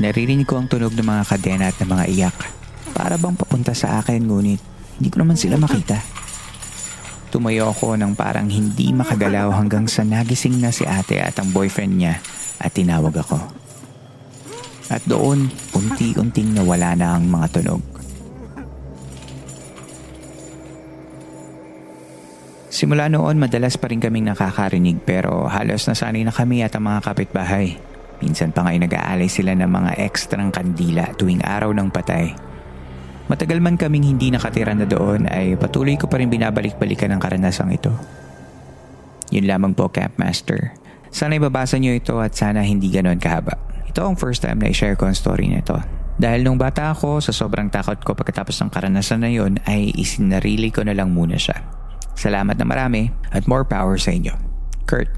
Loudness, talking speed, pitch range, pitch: -19 LUFS, 165 wpm, 90-120 Hz, 105 Hz